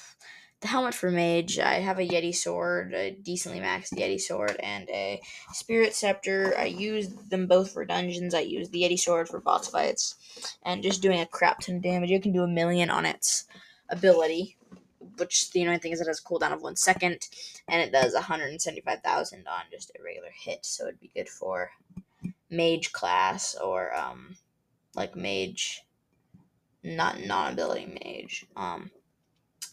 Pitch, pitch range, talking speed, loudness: 180 Hz, 170-195 Hz, 180 wpm, -28 LUFS